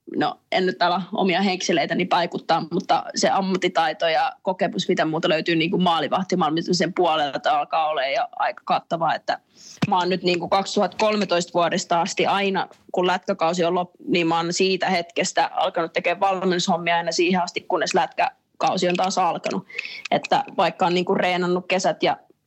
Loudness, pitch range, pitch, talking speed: -22 LUFS, 175-190 Hz, 180 Hz, 165 wpm